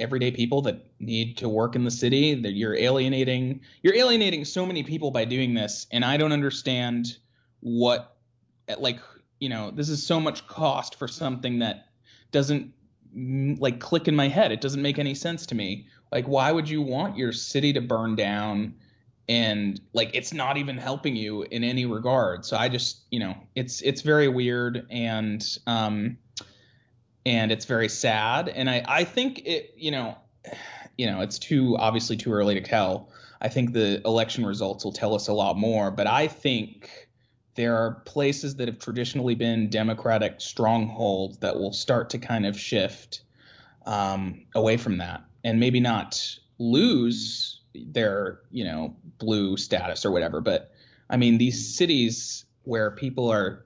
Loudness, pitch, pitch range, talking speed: -25 LUFS, 120 Hz, 110-130 Hz, 170 wpm